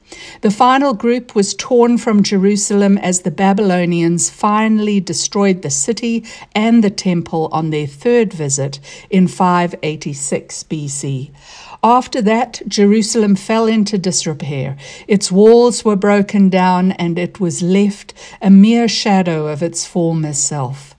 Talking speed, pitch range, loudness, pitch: 130 wpm, 170-215 Hz, -14 LUFS, 195 Hz